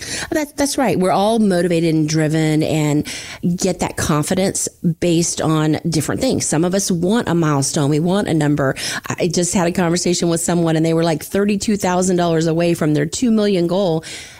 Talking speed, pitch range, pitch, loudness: 180 wpm, 155-185 Hz, 170 Hz, -17 LUFS